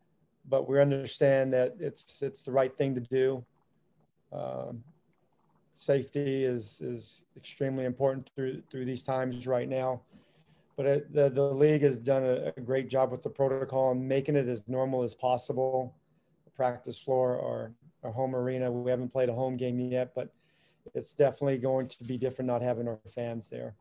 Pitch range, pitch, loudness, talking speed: 125-135 Hz, 130 Hz, -30 LUFS, 175 wpm